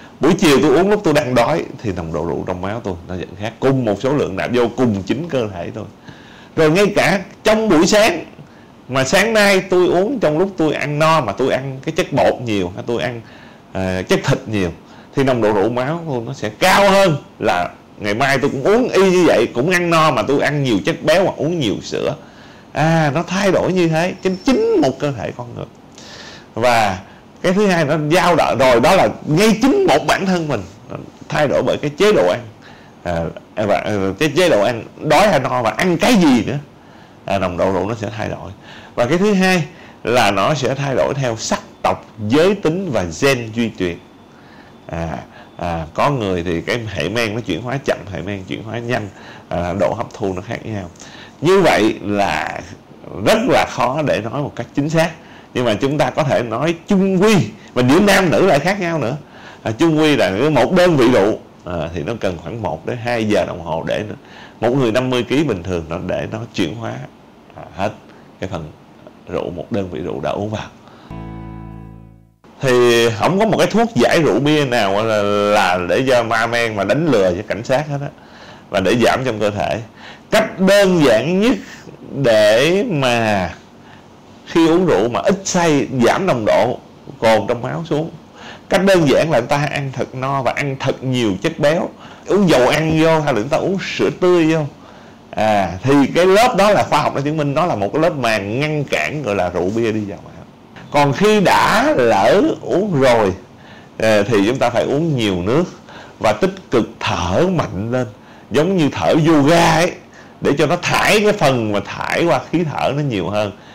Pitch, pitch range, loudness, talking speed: 140 Hz, 110-175 Hz, -16 LUFS, 215 wpm